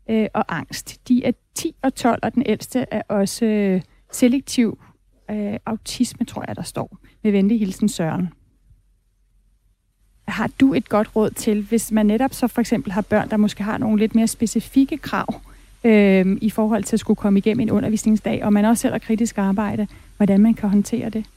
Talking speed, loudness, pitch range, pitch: 185 wpm, -20 LUFS, 205-230 Hz, 215 Hz